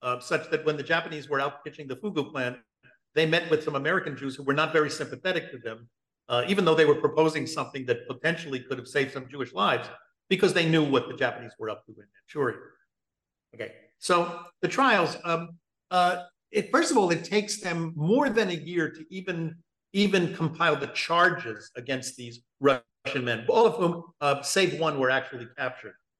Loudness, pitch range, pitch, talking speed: -27 LUFS, 135-175 Hz, 155 Hz, 200 wpm